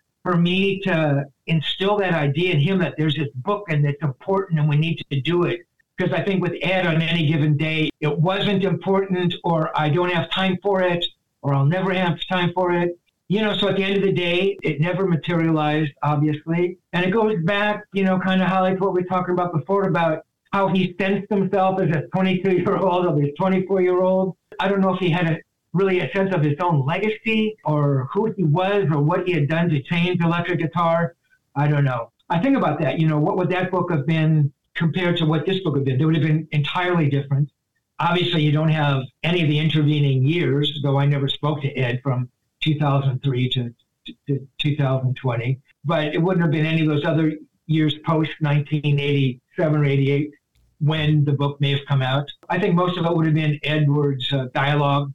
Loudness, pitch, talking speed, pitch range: -21 LUFS, 165 Hz, 210 wpm, 145-185 Hz